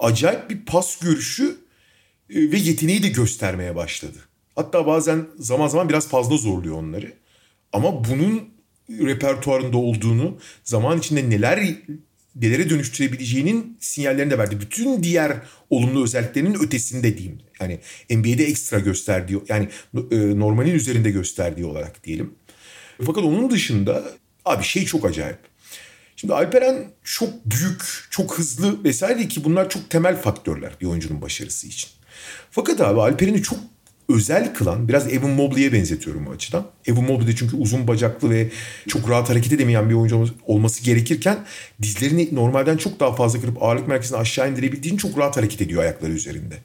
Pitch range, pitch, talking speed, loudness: 110-160 Hz, 130 Hz, 145 wpm, -21 LUFS